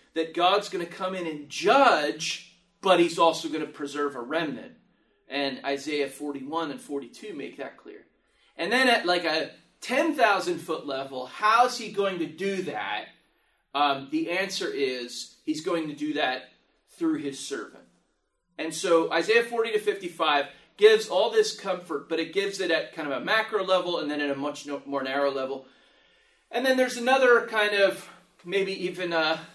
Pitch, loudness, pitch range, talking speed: 170 Hz, -26 LUFS, 145-200 Hz, 180 wpm